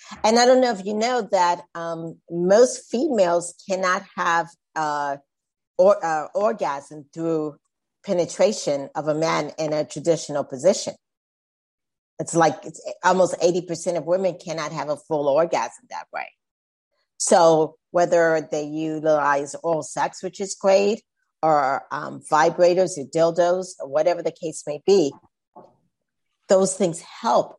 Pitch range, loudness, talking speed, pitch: 155-185 Hz, -22 LUFS, 135 wpm, 165 Hz